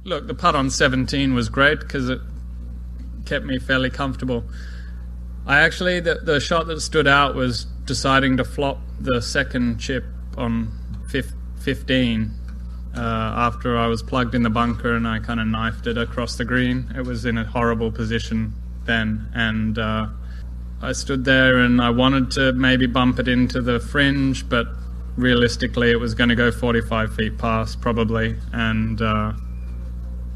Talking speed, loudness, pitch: 165 wpm, -20 LUFS, 115 Hz